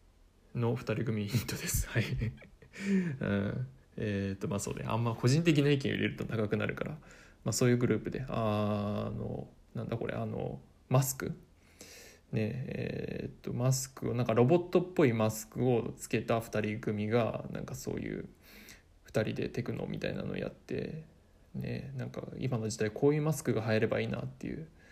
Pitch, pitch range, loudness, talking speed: 115 Hz, 105-130 Hz, -33 LUFS, 315 characters per minute